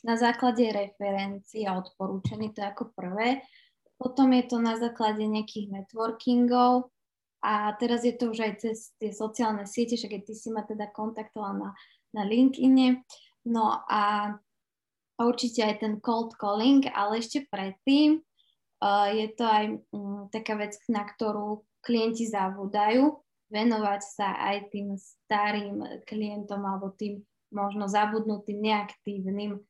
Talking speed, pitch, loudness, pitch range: 135 wpm, 215 Hz, -28 LUFS, 205-235 Hz